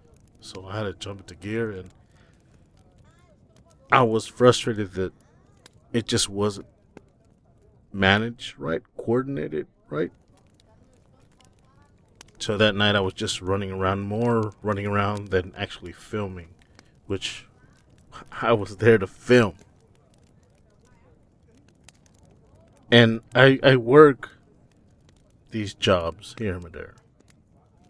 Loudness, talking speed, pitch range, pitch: -23 LUFS, 105 wpm, 95-115 Hz, 105 Hz